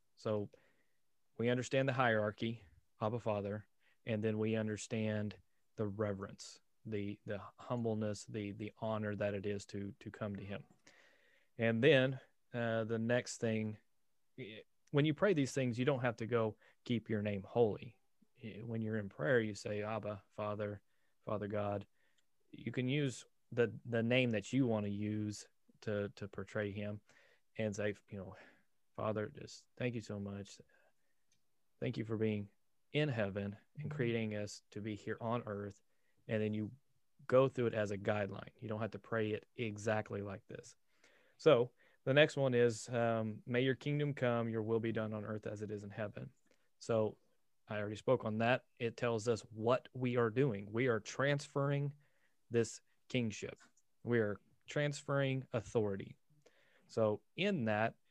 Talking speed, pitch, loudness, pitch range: 165 wpm, 110 Hz, -38 LUFS, 105-120 Hz